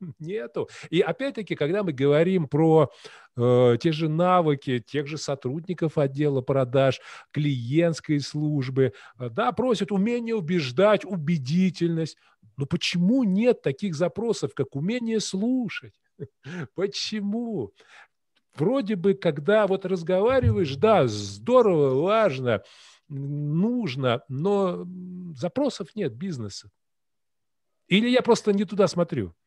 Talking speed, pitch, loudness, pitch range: 105 wpm, 175 Hz, -24 LUFS, 145-205 Hz